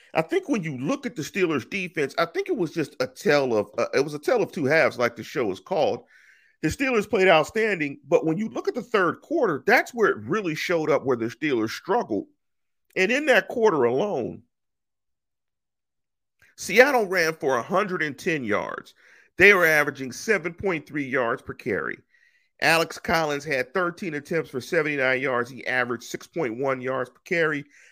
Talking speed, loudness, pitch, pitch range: 180 wpm, -24 LUFS, 175 Hz, 150-235 Hz